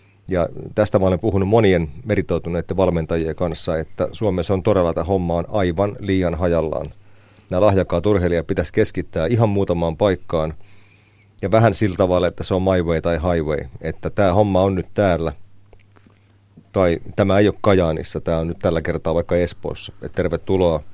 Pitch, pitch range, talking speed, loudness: 95 Hz, 85-100 Hz, 165 wpm, -19 LUFS